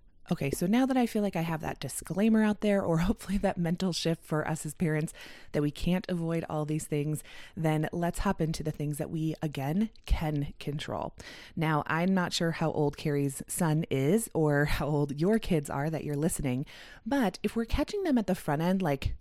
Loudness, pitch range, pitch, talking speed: -30 LUFS, 150-185 Hz, 160 Hz, 210 wpm